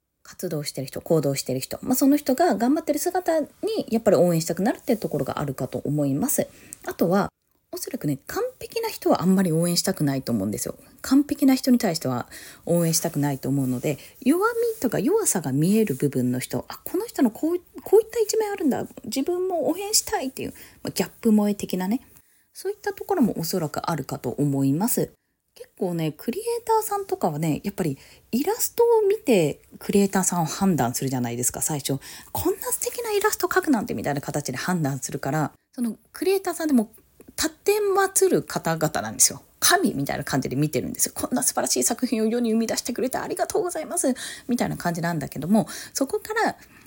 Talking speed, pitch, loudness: 435 characters per minute, 230 Hz, -24 LUFS